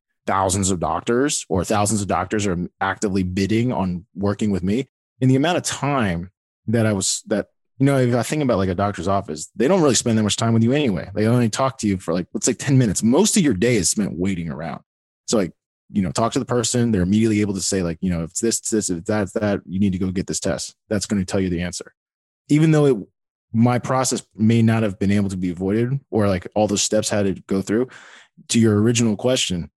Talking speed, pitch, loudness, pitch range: 260 wpm, 105 Hz, -20 LUFS, 95-120 Hz